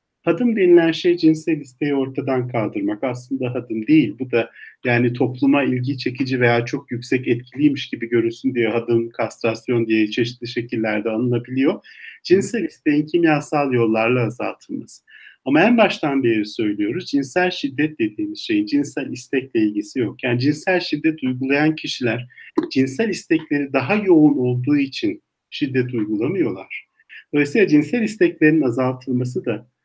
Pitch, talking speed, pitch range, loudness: 140 Hz, 130 wpm, 120-175 Hz, -20 LUFS